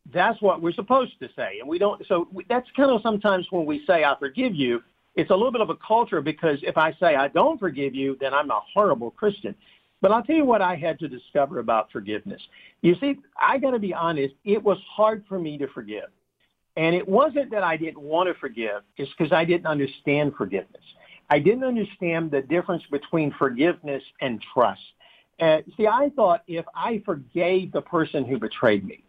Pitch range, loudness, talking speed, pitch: 145-210 Hz, -23 LUFS, 210 wpm, 170 Hz